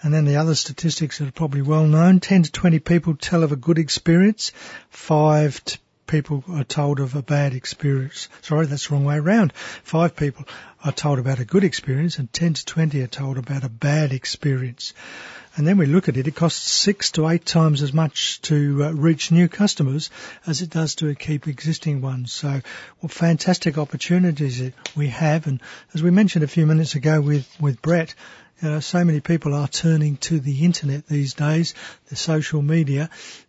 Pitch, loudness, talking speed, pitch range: 155 Hz, -20 LUFS, 195 wpm, 145-165 Hz